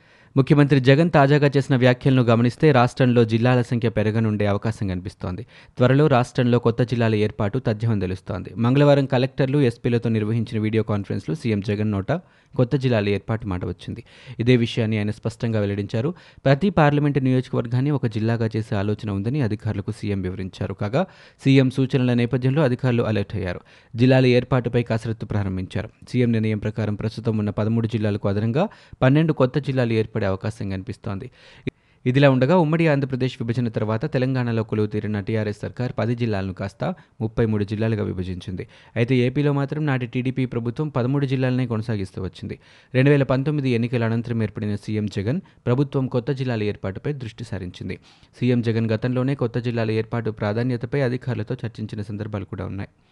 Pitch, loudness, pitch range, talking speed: 120 Hz, -22 LUFS, 105-130 Hz, 140 wpm